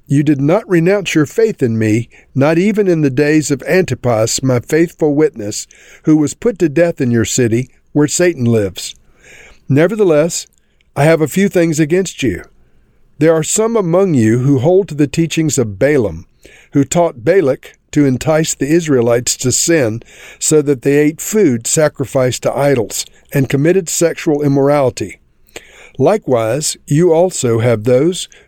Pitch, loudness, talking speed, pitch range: 150 Hz, -13 LUFS, 160 wpm, 130-170 Hz